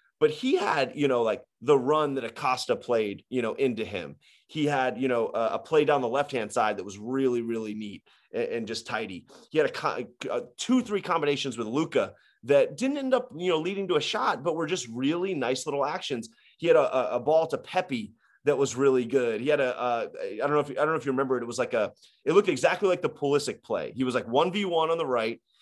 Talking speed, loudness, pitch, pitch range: 250 wpm, -27 LUFS, 155 Hz, 130-210 Hz